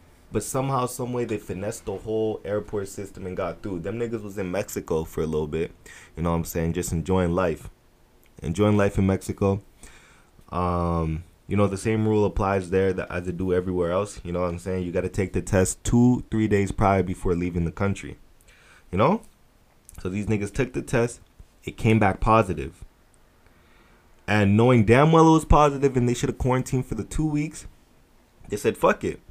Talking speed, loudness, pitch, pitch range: 200 wpm, -24 LUFS, 100 Hz, 90-110 Hz